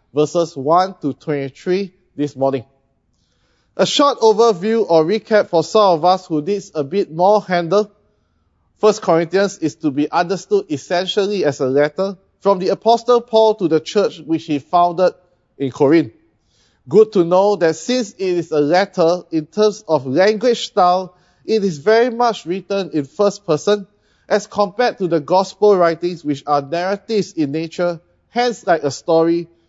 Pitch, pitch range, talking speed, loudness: 180 Hz, 155-205 Hz, 160 wpm, -17 LUFS